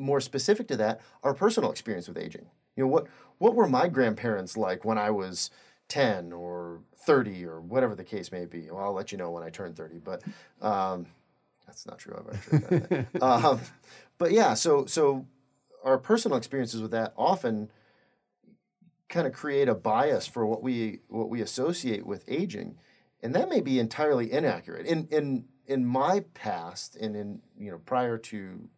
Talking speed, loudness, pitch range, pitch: 180 wpm, -28 LUFS, 100-150 Hz, 120 Hz